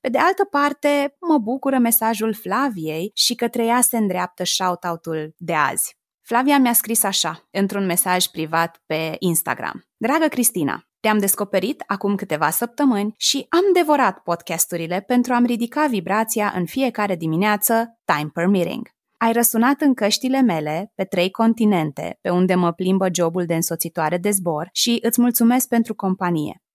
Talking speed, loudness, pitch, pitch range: 155 wpm, -19 LUFS, 205 Hz, 175-245 Hz